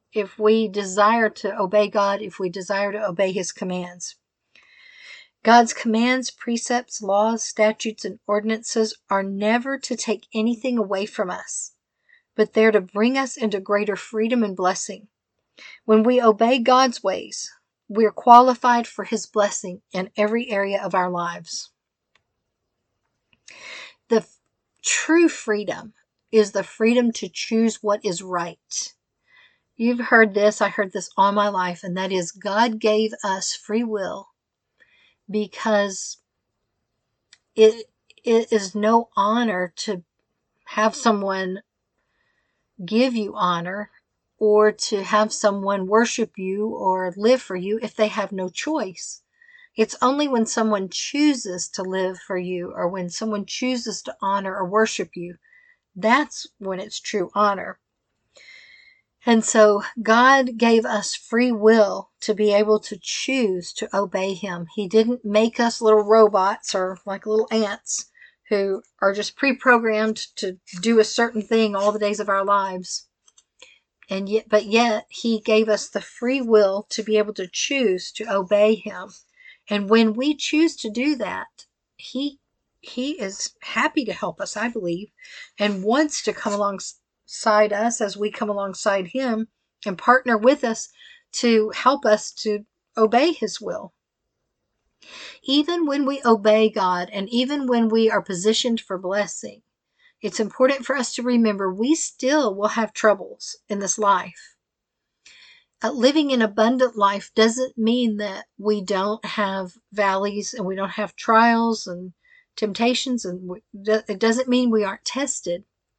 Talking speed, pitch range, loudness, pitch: 145 wpm, 200-235 Hz, -21 LUFS, 215 Hz